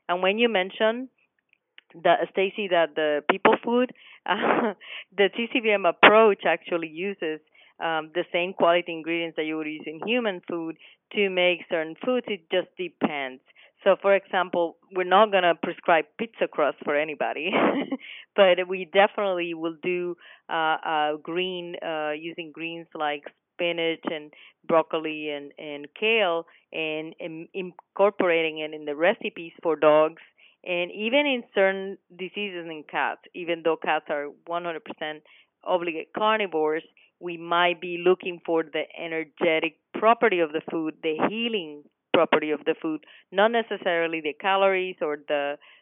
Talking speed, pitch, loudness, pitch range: 145 wpm, 175 Hz, -25 LUFS, 160-195 Hz